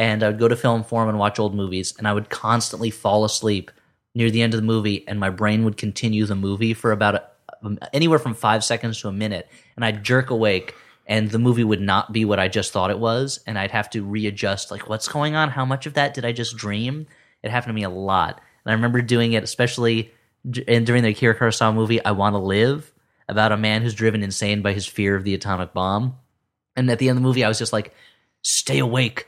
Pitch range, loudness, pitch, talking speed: 105-120 Hz, -21 LUFS, 110 Hz, 245 wpm